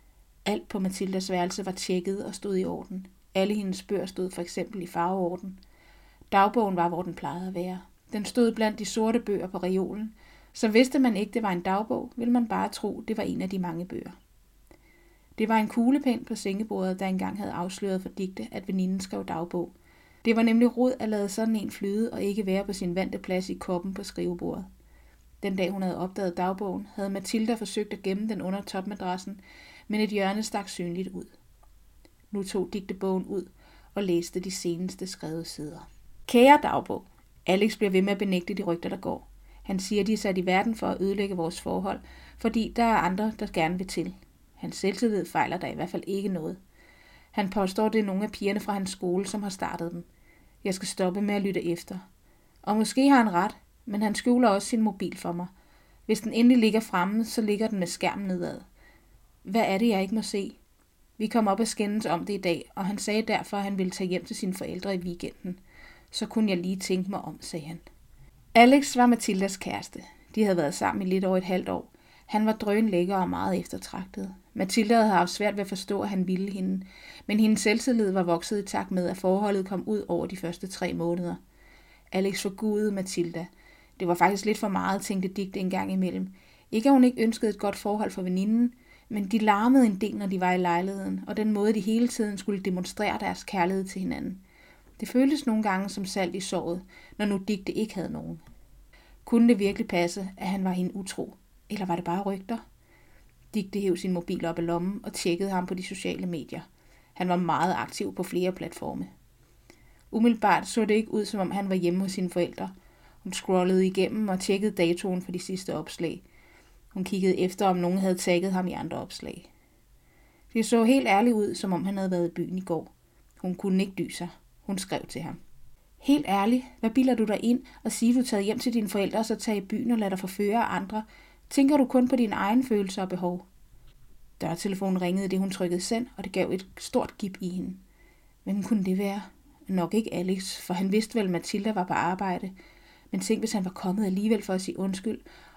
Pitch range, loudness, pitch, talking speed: 185-215 Hz, -28 LUFS, 195 Hz, 215 wpm